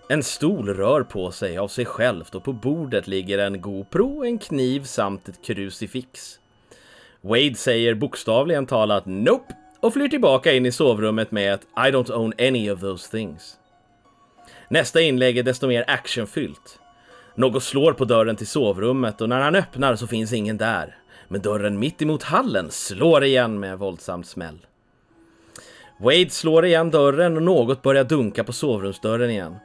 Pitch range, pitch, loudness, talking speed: 105-140 Hz, 120 Hz, -21 LUFS, 165 wpm